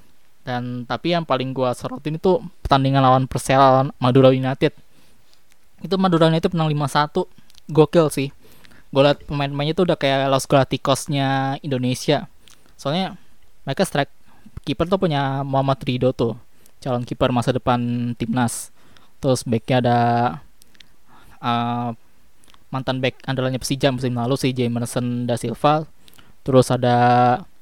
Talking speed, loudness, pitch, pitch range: 125 wpm, -20 LUFS, 135 Hz, 125-145 Hz